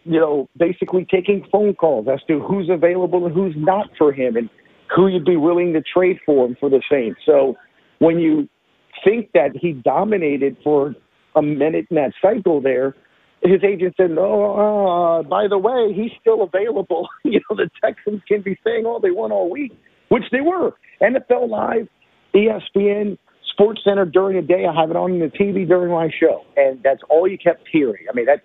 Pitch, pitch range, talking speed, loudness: 185 Hz, 160-205 Hz, 195 wpm, -18 LUFS